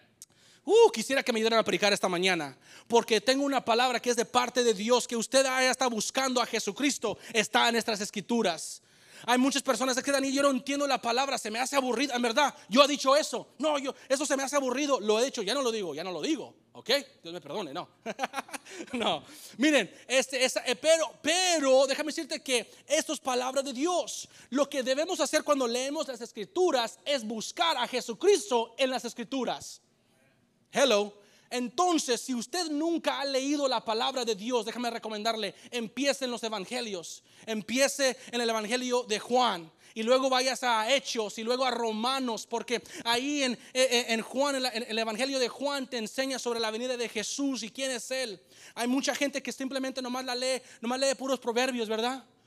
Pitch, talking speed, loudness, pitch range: 250 Hz, 200 wpm, -28 LUFS, 230-275 Hz